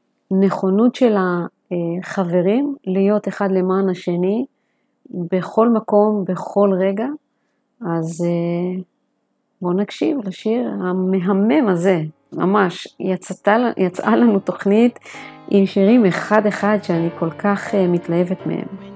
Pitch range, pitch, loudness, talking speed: 180-210 Hz, 195 Hz, -18 LUFS, 100 wpm